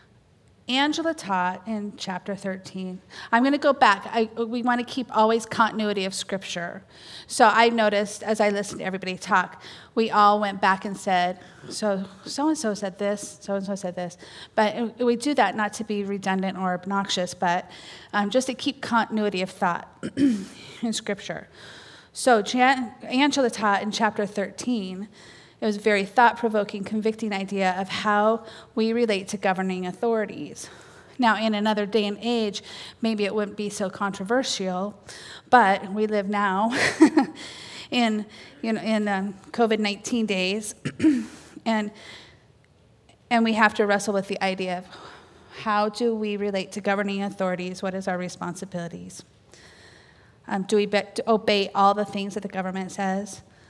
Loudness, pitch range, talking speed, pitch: -24 LUFS, 195-225 Hz, 160 wpm, 205 Hz